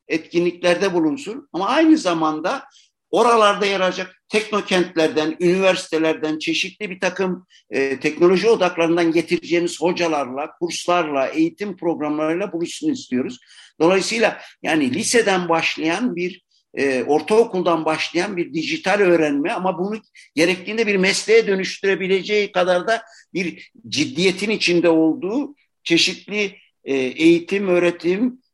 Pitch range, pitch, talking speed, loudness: 165-205 Hz, 180 Hz, 105 wpm, -19 LUFS